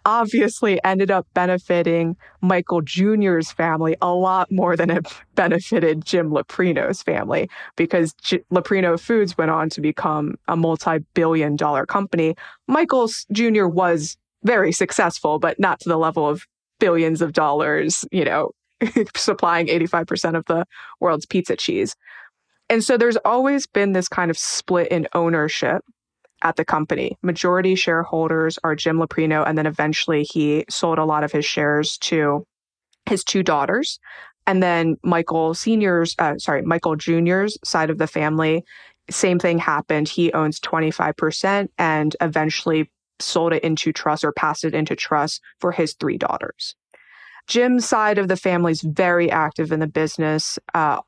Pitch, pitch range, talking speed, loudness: 170 Hz, 155-185 Hz, 155 wpm, -20 LUFS